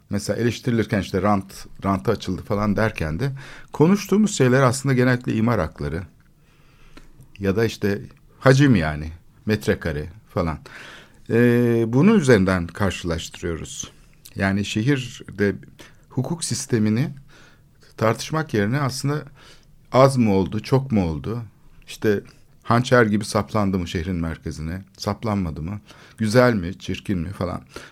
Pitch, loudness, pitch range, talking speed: 110 Hz, -21 LUFS, 95-135 Hz, 115 wpm